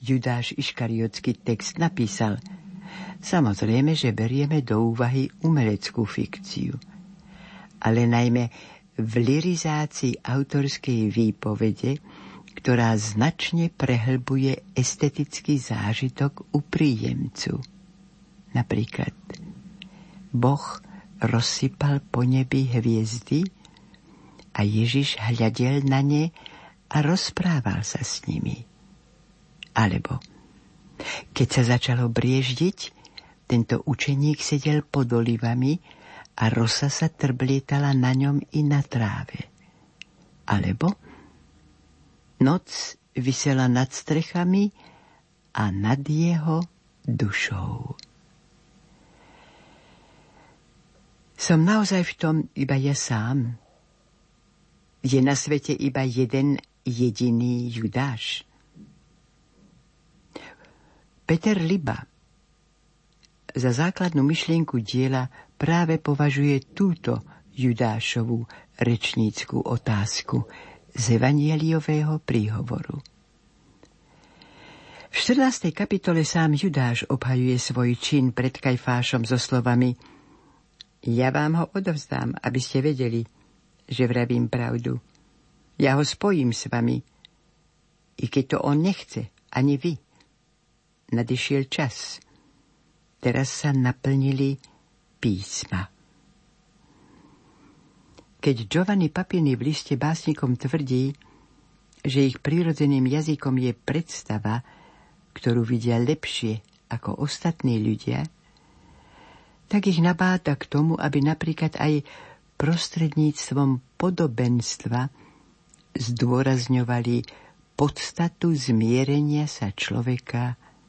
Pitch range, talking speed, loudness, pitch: 120-155 Hz, 85 wpm, -24 LUFS, 135 Hz